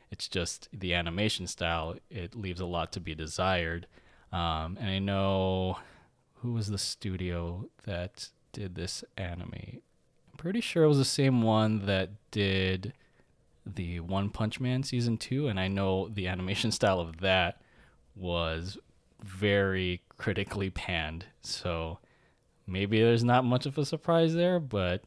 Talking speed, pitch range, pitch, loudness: 150 wpm, 90-115 Hz, 95 Hz, -31 LUFS